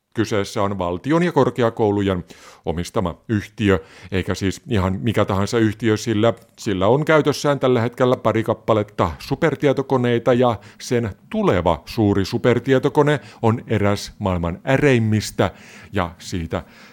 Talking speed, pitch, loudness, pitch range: 115 wpm, 110 Hz, -20 LUFS, 95-125 Hz